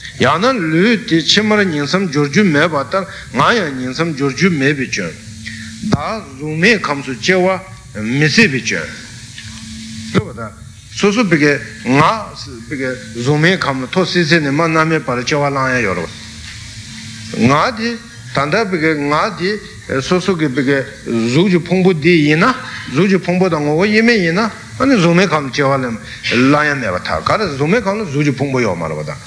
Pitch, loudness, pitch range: 145 Hz, -14 LUFS, 120-180 Hz